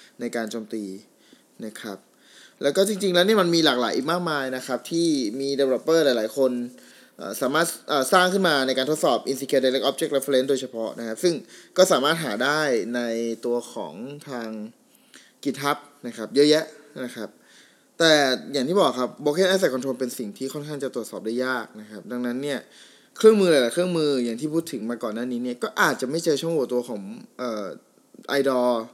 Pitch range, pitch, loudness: 120-155 Hz, 135 Hz, -23 LUFS